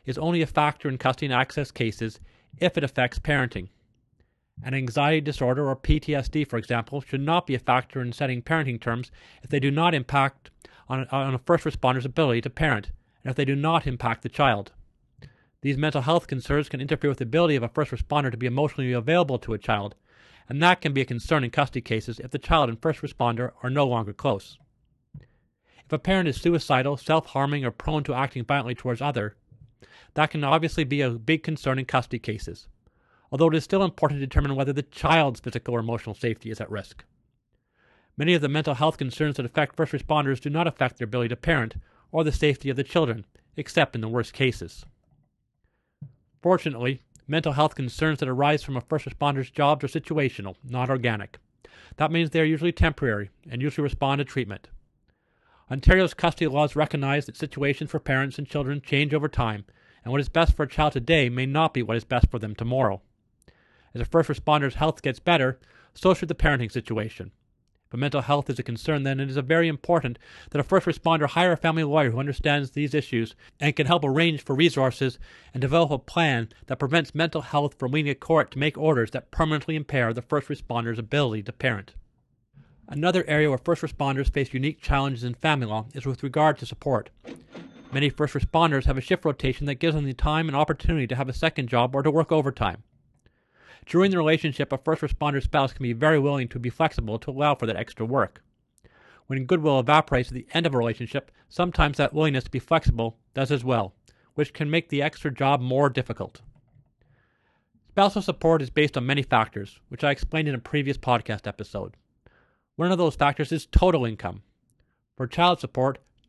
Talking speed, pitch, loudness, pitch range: 200 wpm, 140 Hz, -25 LUFS, 125-155 Hz